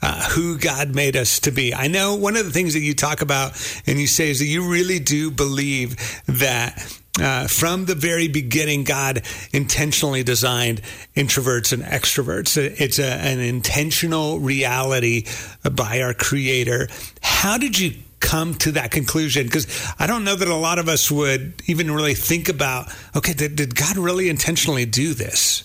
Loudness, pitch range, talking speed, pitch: -19 LUFS, 125-160 Hz, 175 wpm, 140 Hz